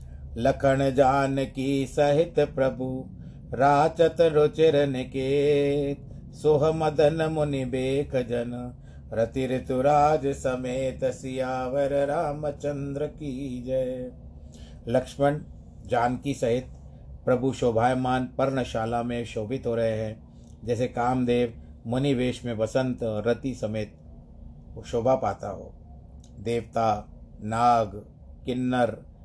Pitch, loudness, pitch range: 130 Hz, -26 LUFS, 120-140 Hz